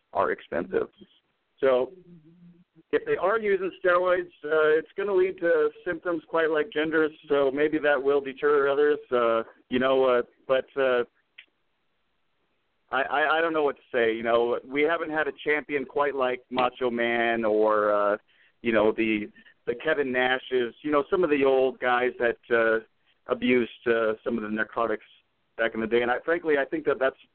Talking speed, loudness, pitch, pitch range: 180 wpm, -25 LUFS, 140 Hz, 120-160 Hz